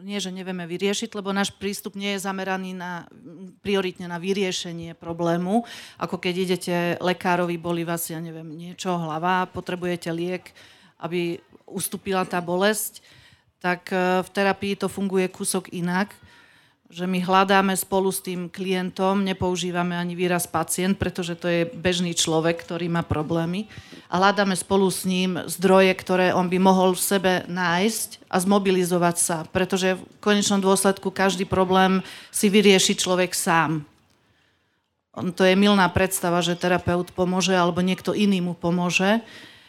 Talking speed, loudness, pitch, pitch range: 145 wpm, -23 LUFS, 185 Hz, 175-195 Hz